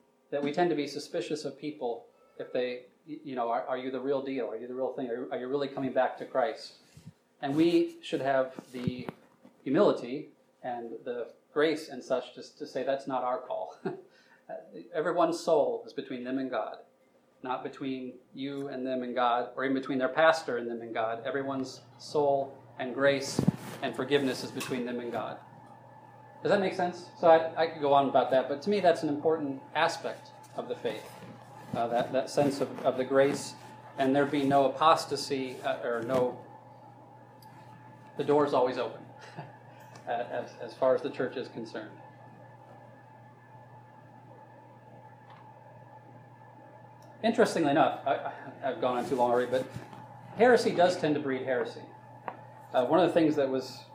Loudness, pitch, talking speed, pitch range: -30 LUFS, 135 Hz, 175 wpm, 125-145 Hz